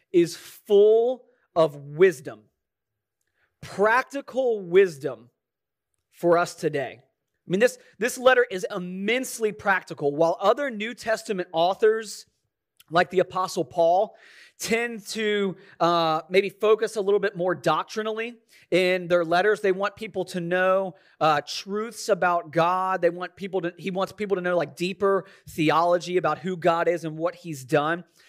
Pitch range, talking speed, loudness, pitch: 170-215 Hz, 145 wpm, -24 LUFS, 185 Hz